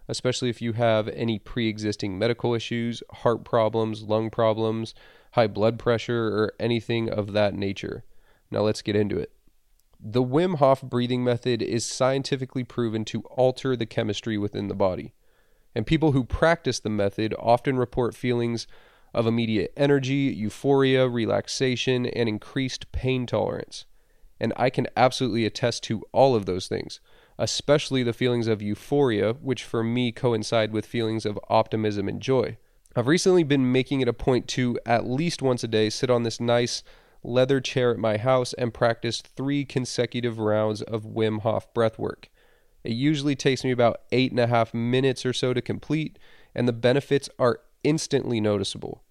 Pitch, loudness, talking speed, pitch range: 120 Hz, -25 LUFS, 165 wpm, 110-130 Hz